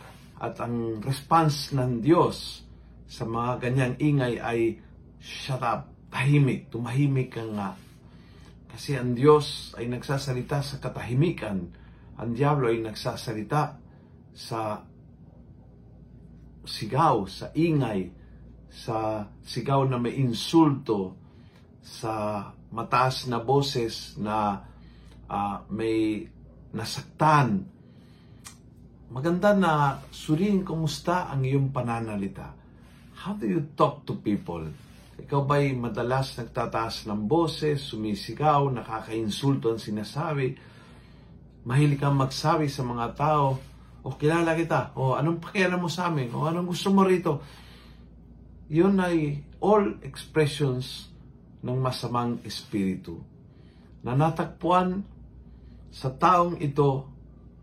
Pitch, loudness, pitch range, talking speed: 130 Hz, -26 LUFS, 115-150 Hz, 105 wpm